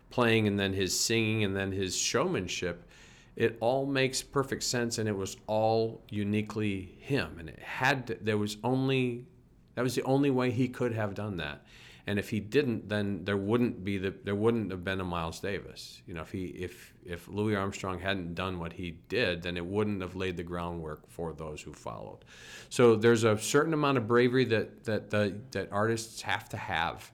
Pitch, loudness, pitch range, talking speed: 105 Hz, -31 LUFS, 95-115 Hz, 205 wpm